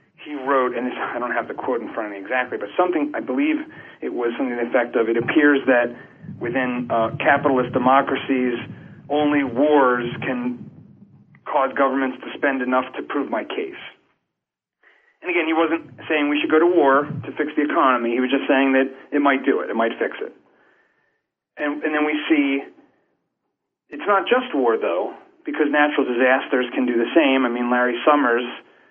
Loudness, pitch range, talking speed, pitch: -20 LUFS, 125-150 Hz, 190 wpm, 140 Hz